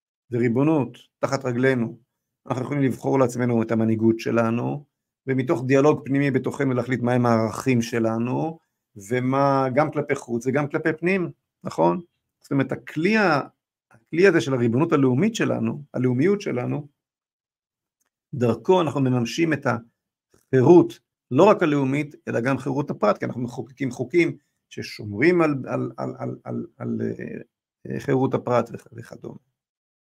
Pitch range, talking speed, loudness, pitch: 120-150 Hz, 130 wpm, -22 LUFS, 130 Hz